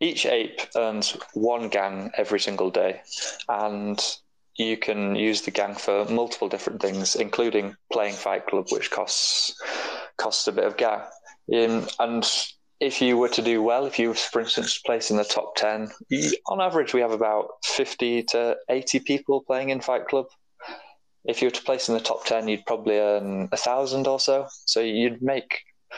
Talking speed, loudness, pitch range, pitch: 180 wpm, -25 LUFS, 110-135 Hz, 115 Hz